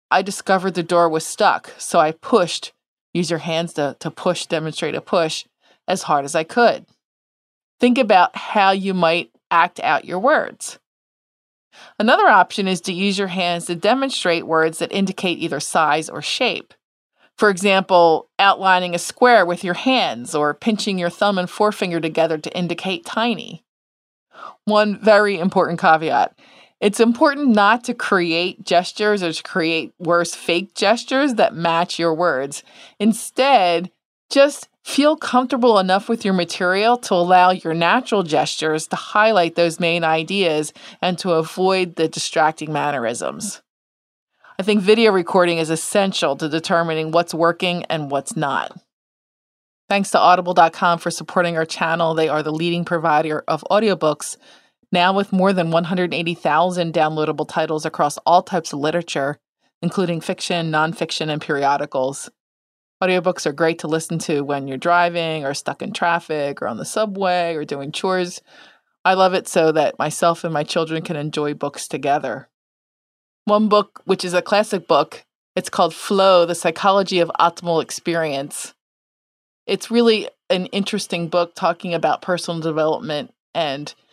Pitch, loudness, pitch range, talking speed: 175 Hz, -18 LUFS, 160-195 Hz, 150 wpm